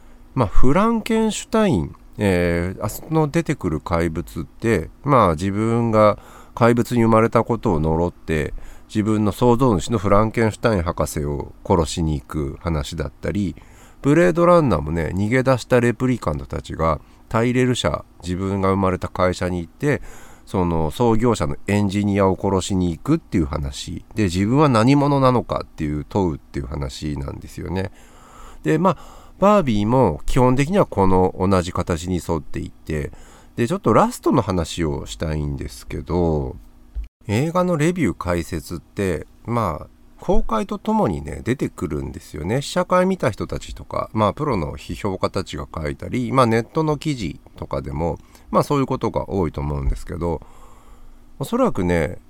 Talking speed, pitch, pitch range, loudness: 340 characters per minute, 95 Hz, 80-125 Hz, -21 LUFS